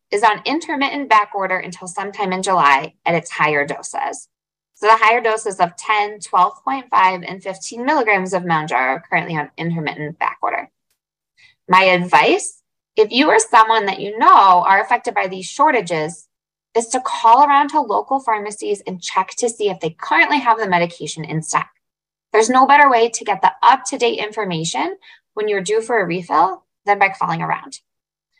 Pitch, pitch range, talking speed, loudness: 205 Hz, 180-240 Hz, 175 wpm, -16 LUFS